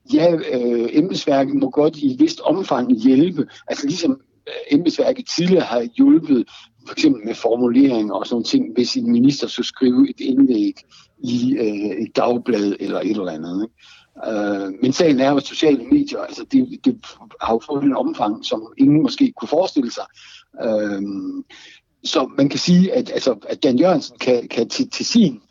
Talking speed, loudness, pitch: 175 wpm, -18 LUFS, 255 Hz